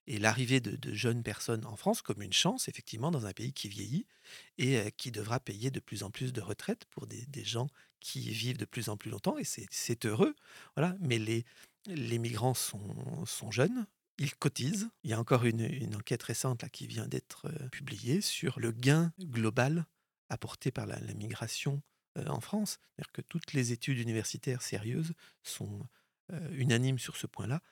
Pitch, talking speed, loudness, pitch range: 130 Hz, 200 wpm, -35 LUFS, 115-150 Hz